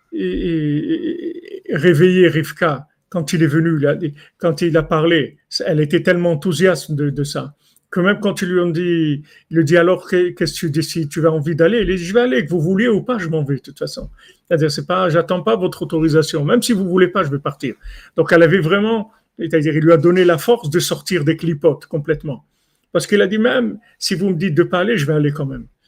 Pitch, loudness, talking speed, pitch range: 170 Hz, -17 LUFS, 235 wpm, 160-190 Hz